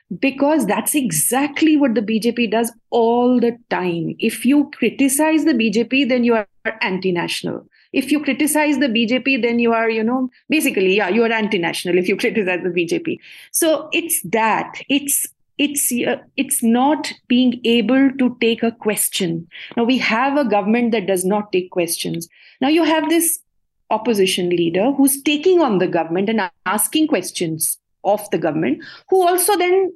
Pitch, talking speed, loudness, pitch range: 235 Hz, 170 wpm, -18 LUFS, 205-285 Hz